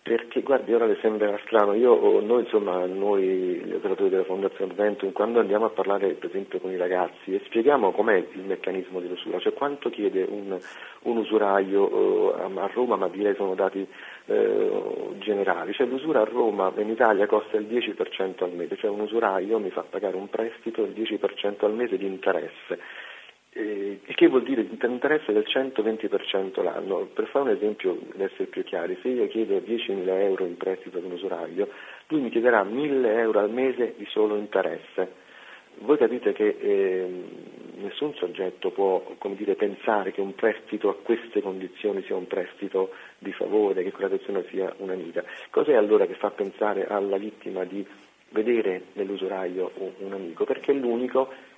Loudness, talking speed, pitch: -26 LUFS, 175 wpm, 350 Hz